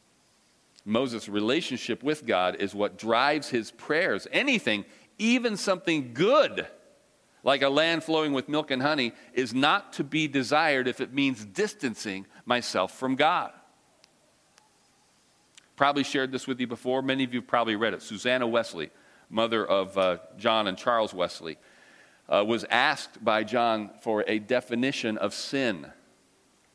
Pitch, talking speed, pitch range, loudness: 130 Hz, 145 wpm, 115-145 Hz, -27 LUFS